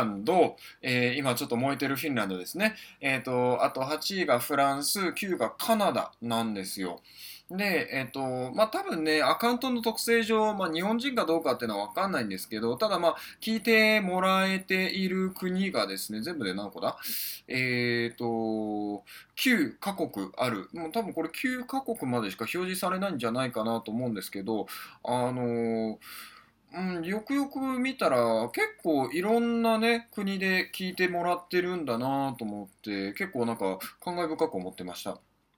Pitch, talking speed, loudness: 160 Hz, 335 characters per minute, -29 LUFS